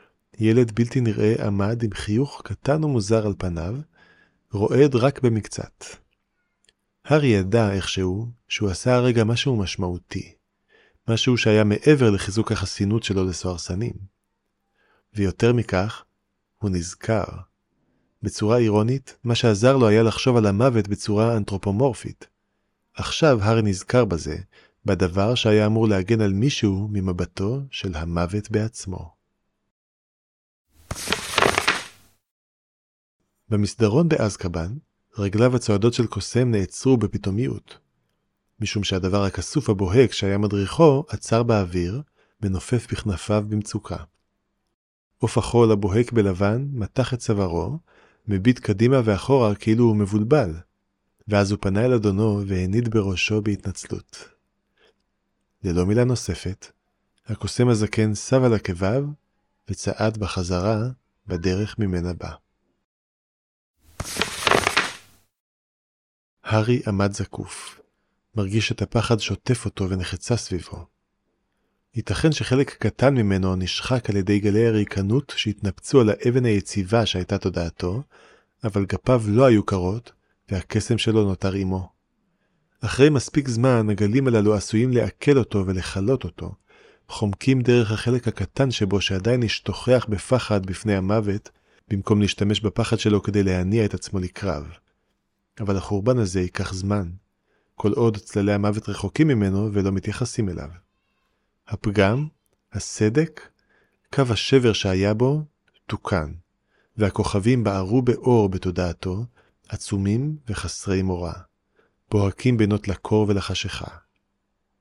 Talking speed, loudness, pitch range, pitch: 105 wpm, -22 LUFS, 95-115 Hz, 105 Hz